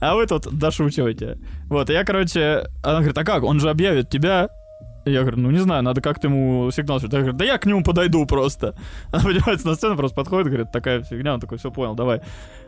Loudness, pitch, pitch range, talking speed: -20 LUFS, 145 Hz, 125-165 Hz, 225 wpm